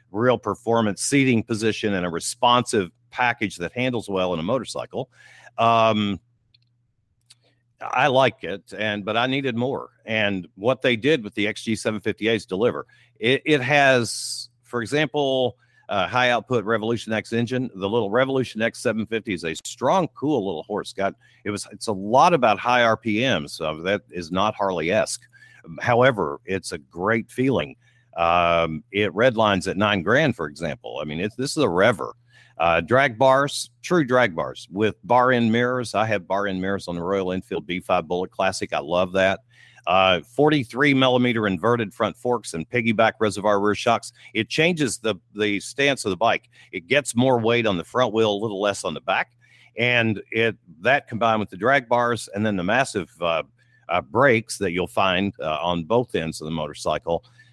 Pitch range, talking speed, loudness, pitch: 100-125 Hz, 175 wpm, -22 LUFS, 115 Hz